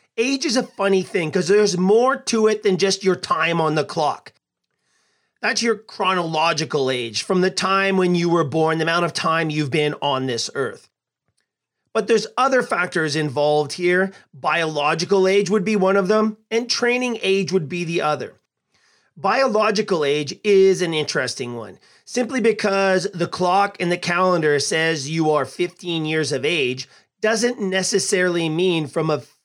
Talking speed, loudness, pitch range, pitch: 165 wpm, -20 LUFS, 160-210 Hz, 185 Hz